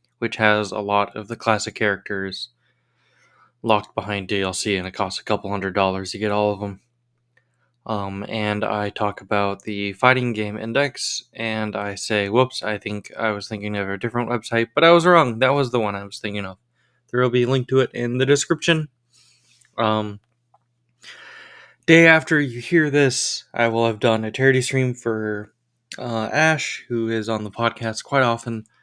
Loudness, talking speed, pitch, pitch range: -21 LUFS, 185 wpm, 115 Hz, 105-125 Hz